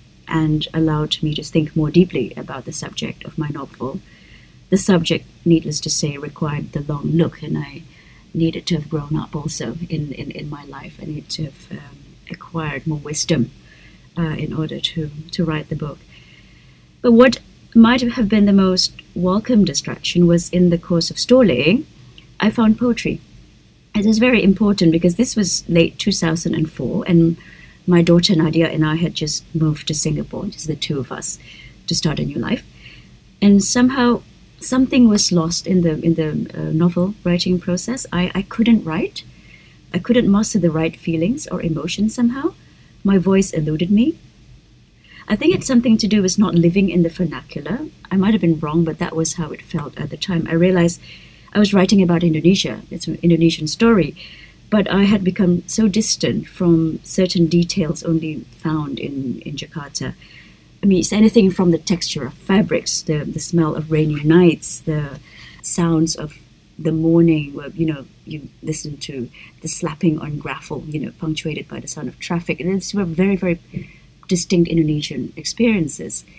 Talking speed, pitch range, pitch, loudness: 180 wpm, 155-195 Hz, 170 Hz, -18 LUFS